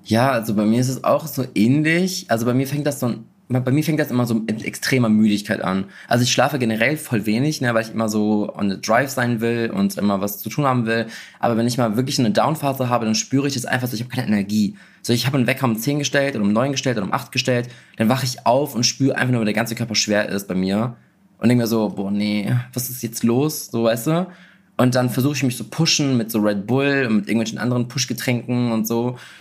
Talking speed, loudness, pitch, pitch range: 265 wpm, -20 LUFS, 120 Hz, 110-130 Hz